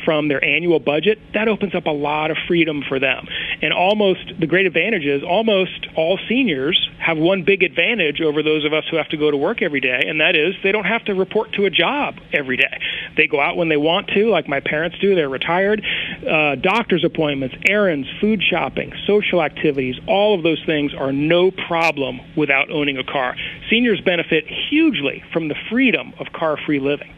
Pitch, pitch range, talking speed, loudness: 165 Hz, 150-200 Hz, 205 wpm, -18 LUFS